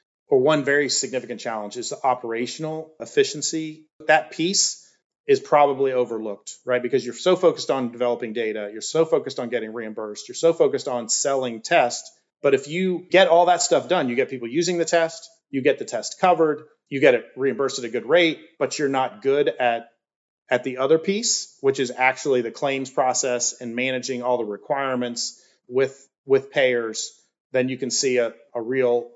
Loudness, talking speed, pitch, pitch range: -22 LUFS, 185 wpm, 135 Hz, 120-160 Hz